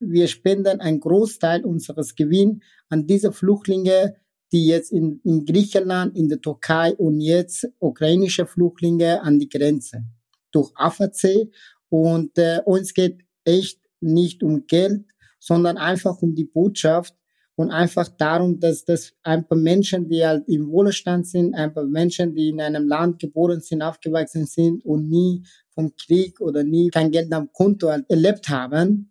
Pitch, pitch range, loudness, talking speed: 170 Hz, 160-185 Hz, -20 LUFS, 155 wpm